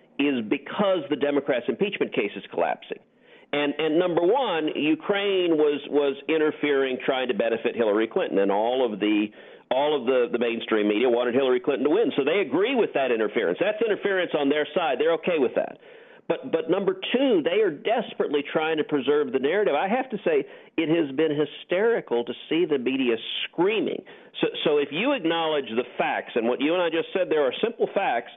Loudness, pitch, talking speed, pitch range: -24 LUFS, 150 Hz, 200 wpm, 130-205 Hz